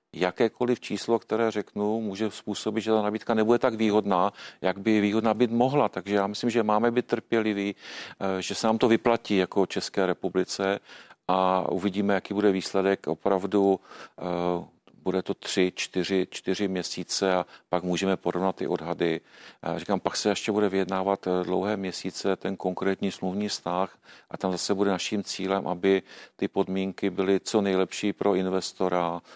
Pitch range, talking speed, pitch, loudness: 95-105 Hz, 155 wpm, 95 Hz, -27 LUFS